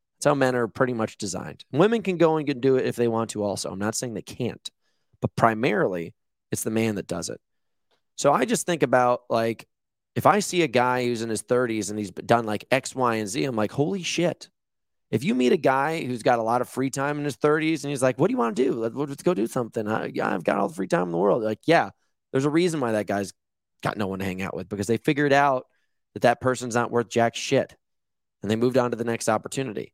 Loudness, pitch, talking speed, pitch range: -24 LUFS, 125 Hz, 260 wpm, 110-140 Hz